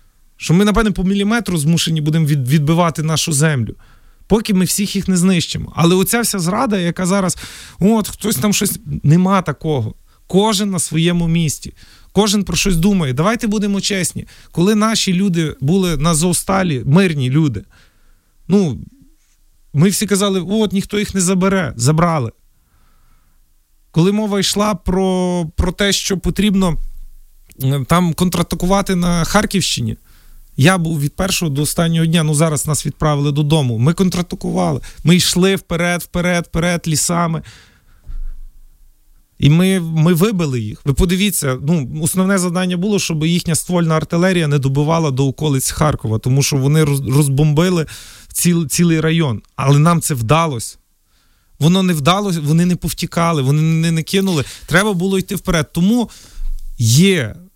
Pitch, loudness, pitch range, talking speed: 165 Hz, -15 LUFS, 145-190 Hz, 140 wpm